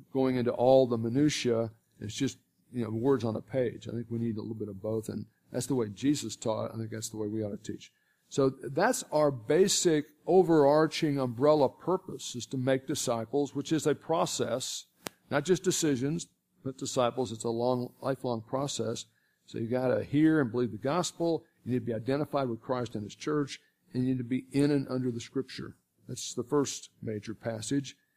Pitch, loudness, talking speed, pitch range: 130 Hz, -30 LUFS, 205 wpm, 115-145 Hz